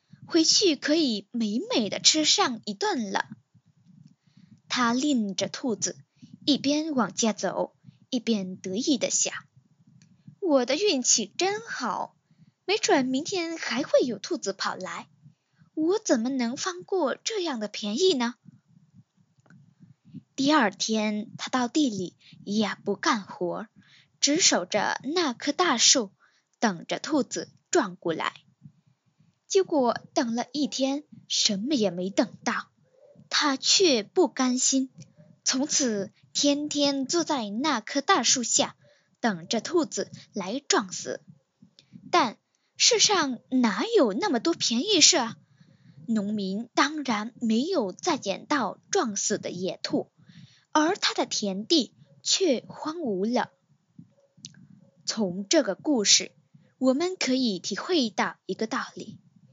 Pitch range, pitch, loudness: 195-300 Hz, 240 Hz, -25 LUFS